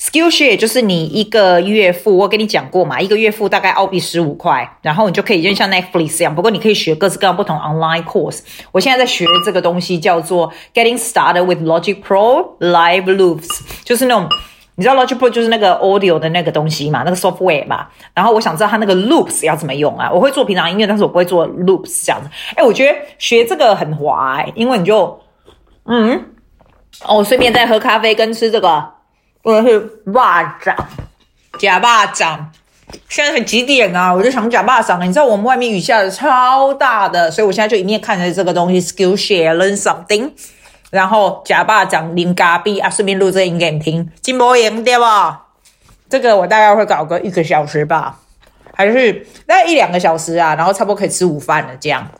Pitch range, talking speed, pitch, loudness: 175-225 Hz, 405 characters per minute, 195 Hz, -12 LUFS